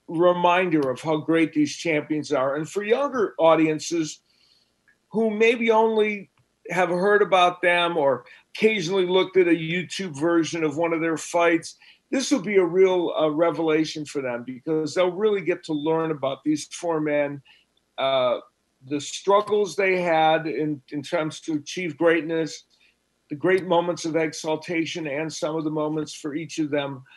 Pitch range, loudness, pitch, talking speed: 155-185 Hz, -23 LUFS, 165 Hz, 165 wpm